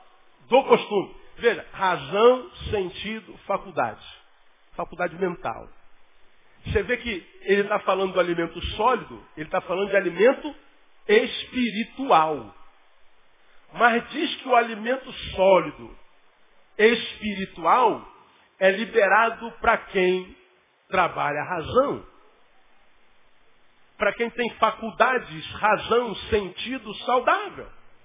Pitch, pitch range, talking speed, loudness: 215 Hz, 185-240 Hz, 90 wpm, -23 LUFS